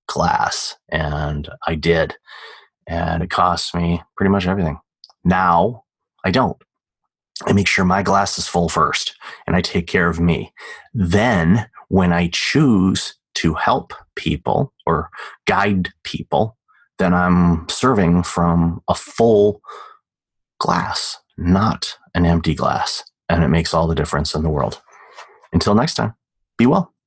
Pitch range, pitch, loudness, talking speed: 80-90 Hz, 85 Hz, -18 LUFS, 140 wpm